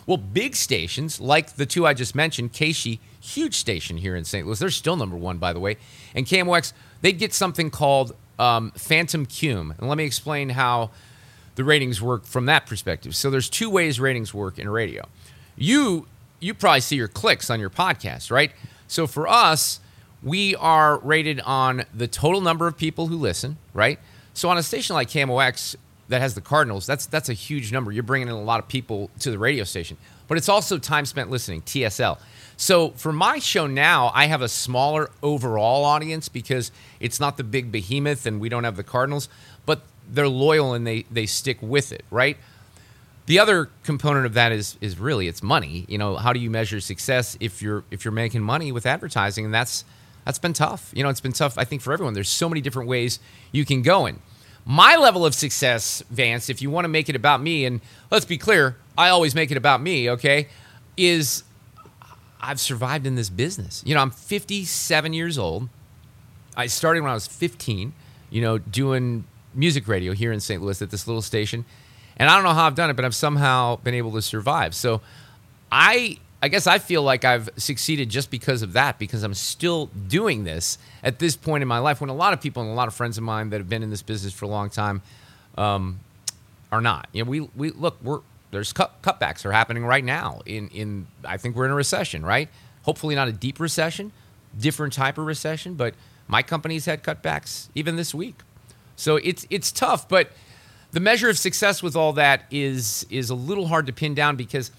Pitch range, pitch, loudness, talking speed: 115-155 Hz, 130 Hz, -22 LUFS, 210 wpm